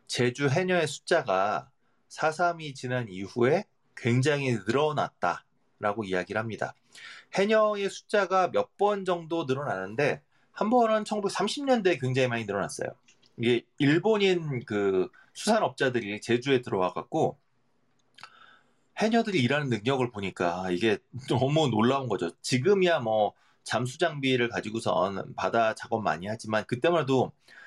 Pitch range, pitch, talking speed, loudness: 115-175 Hz, 130 Hz, 285 characters per minute, -27 LUFS